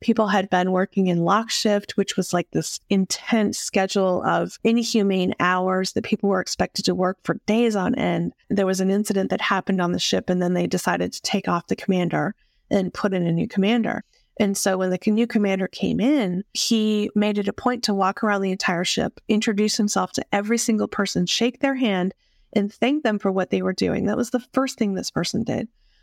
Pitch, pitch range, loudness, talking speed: 200 Hz, 185-220 Hz, -22 LUFS, 215 wpm